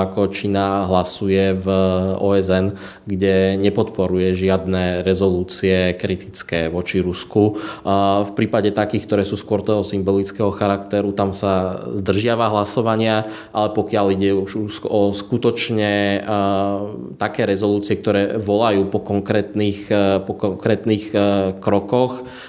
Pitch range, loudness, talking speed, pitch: 95-105 Hz, -19 LUFS, 105 wpm, 100 Hz